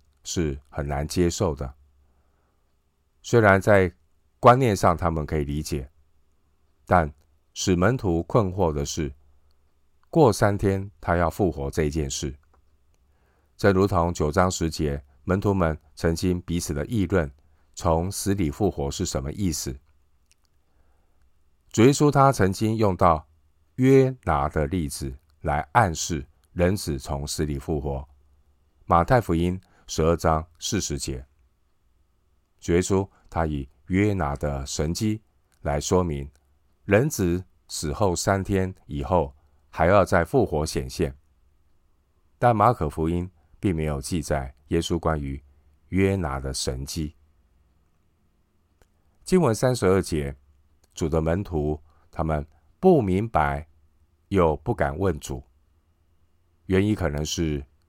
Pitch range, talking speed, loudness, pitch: 75-90 Hz, 175 characters per minute, -24 LUFS, 80 Hz